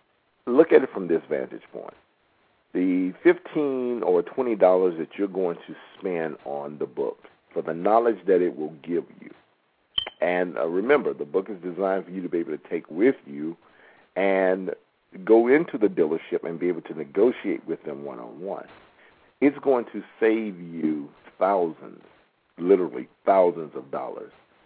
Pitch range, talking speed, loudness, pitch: 85-110 Hz, 165 wpm, -25 LUFS, 95 Hz